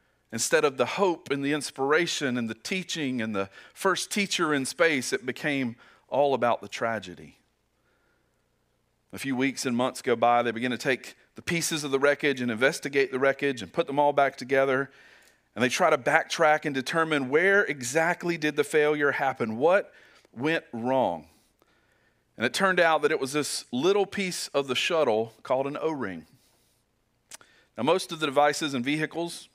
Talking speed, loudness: 180 wpm, -26 LUFS